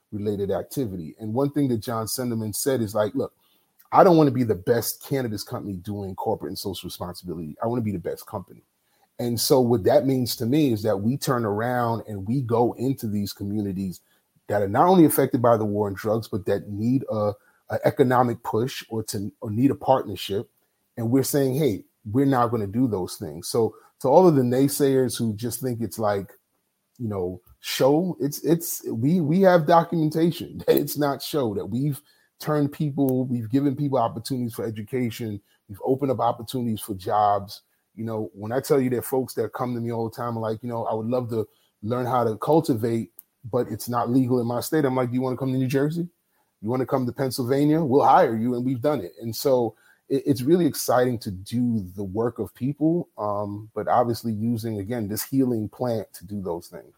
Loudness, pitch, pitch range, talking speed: -24 LUFS, 120 Hz, 110-135 Hz, 215 wpm